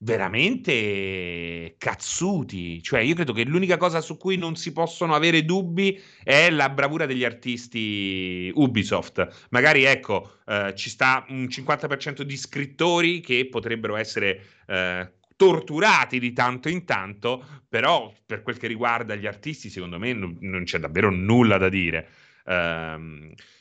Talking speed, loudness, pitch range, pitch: 140 wpm, -23 LUFS, 95-155 Hz, 120 Hz